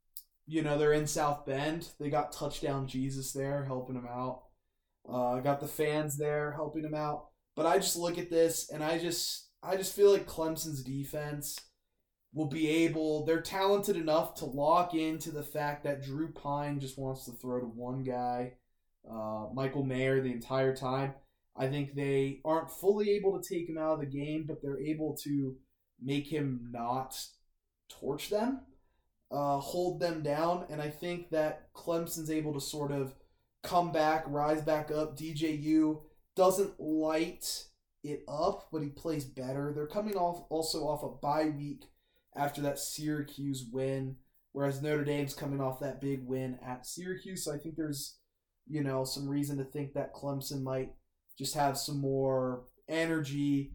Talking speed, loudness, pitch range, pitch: 170 wpm, -34 LUFS, 135-160 Hz, 145 Hz